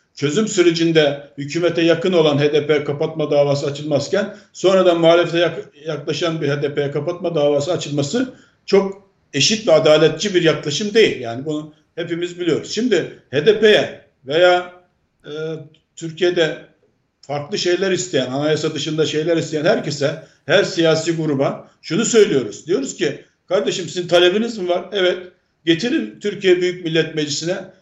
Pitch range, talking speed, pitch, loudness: 150-180 Hz, 125 wpm, 165 Hz, -18 LUFS